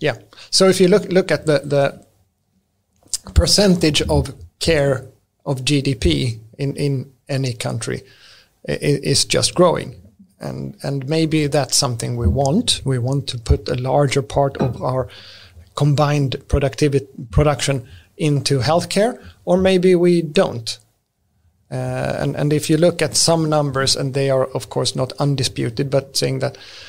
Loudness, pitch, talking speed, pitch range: -18 LUFS, 135 Hz, 145 wpm, 115-150 Hz